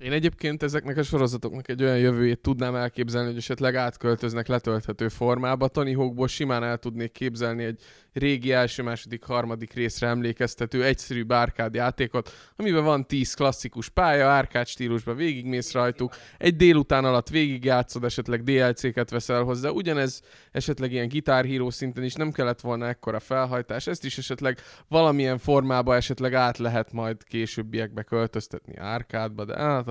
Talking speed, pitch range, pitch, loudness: 145 wpm, 120-135 Hz, 125 Hz, -25 LUFS